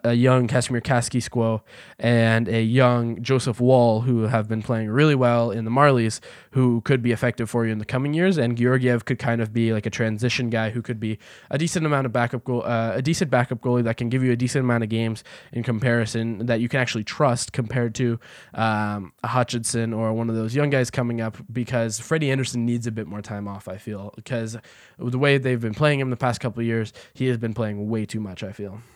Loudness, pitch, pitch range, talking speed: -23 LUFS, 120 Hz, 115-125 Hz, 235 wpm